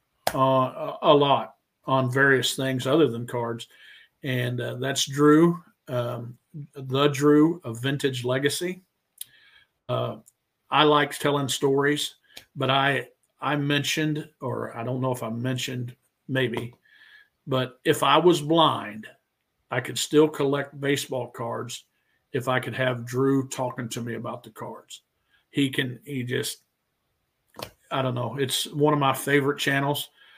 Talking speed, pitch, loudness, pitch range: 140 wpm, 135 Hz, -24 LUFS, 125-145 Hz